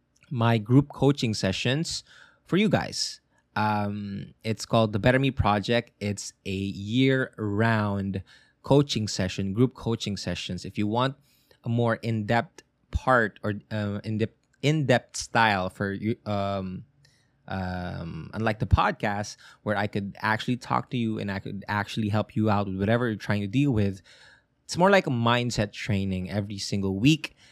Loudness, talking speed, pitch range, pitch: -26 LUFS, 160 wpm, 100-125 Hz, 110 Hz